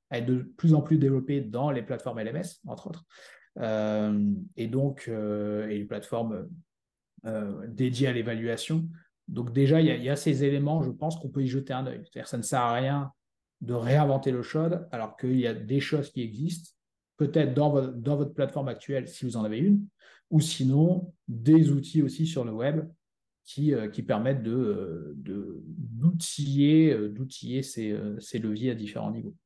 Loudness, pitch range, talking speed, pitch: -28 LUFS, 115-155 Hz, 190 wpm, 135 Hz